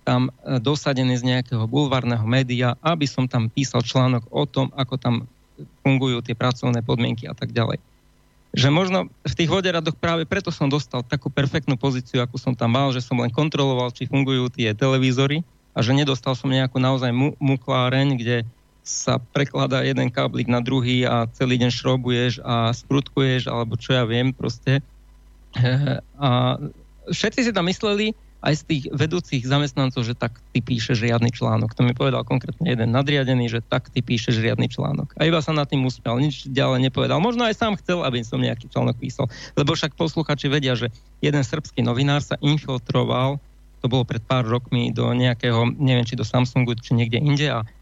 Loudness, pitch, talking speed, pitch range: -22 LUFS, 130 Hz, 180 wpm, 120-145 Hz